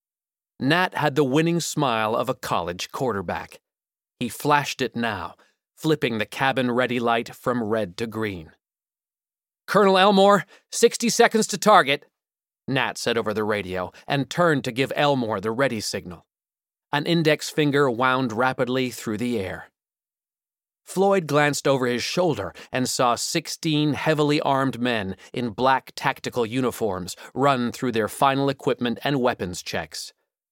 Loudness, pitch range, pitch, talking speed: -23 LUFS, 120-150 Hz, 130 Hz, 140 wpm